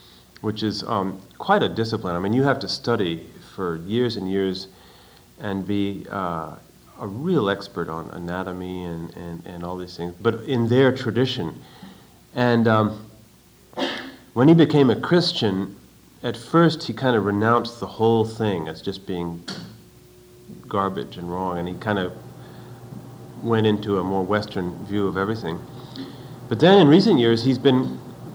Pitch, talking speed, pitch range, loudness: 105 Hz, 160 wpm, 90-120 Hz, -22 LUFS